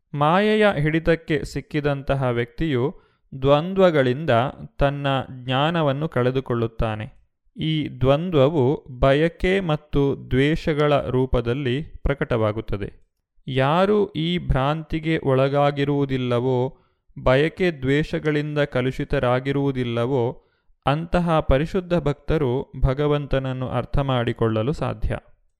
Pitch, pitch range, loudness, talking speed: 140 Hz, 125-155 Hz, -22 LUFS, 65 wpm